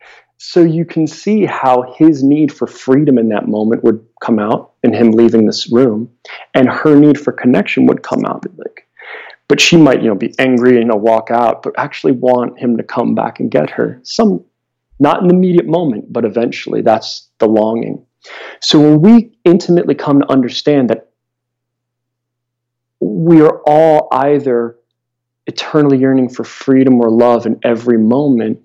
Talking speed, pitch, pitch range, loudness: 170 wpm, 125 Hz, 120-150 Hz, -11 LUFS